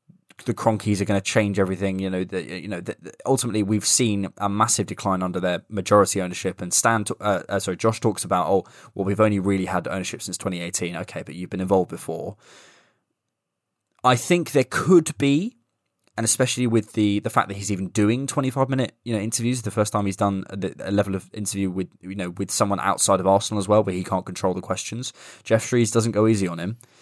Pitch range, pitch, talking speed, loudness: 95-115 Hz, 105 Hz, 220 wpm, -23 LUFS